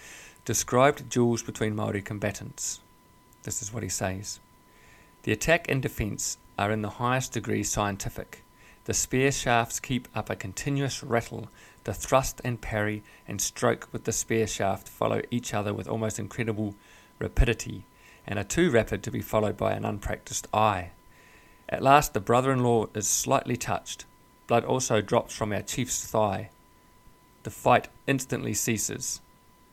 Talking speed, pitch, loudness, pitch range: 155 wpm, 110 Hz, -28 LUFS, 105-120 Hz